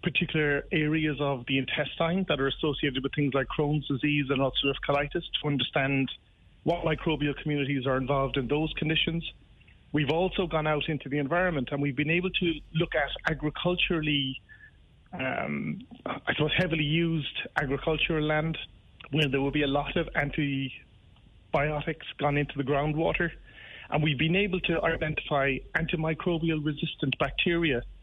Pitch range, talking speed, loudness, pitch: 140-160 Hz, 150 wpm, -28 LUFS, 150 Hz